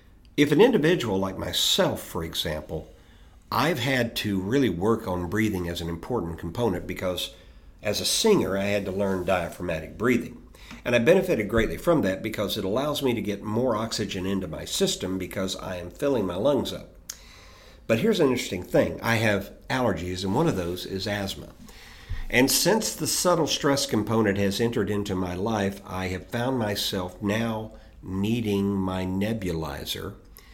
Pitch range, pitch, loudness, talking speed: 90-115 Hz, 100 Hz, -25 LUFS, 165 wpm